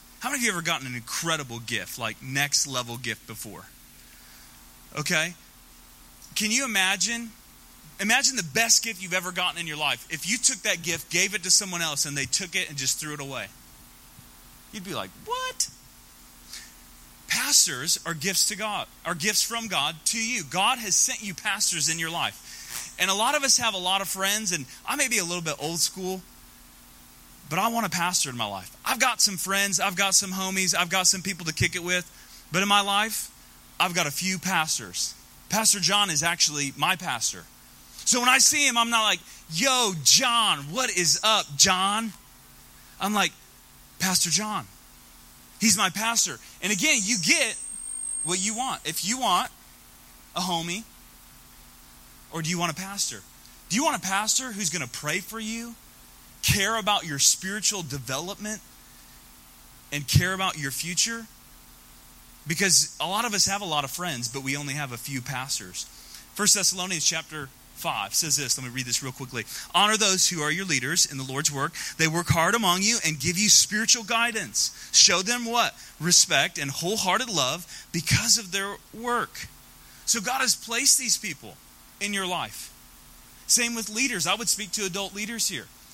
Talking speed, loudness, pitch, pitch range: 185 wpm, -23 LUFS, 175 Hz, 130-210 Hz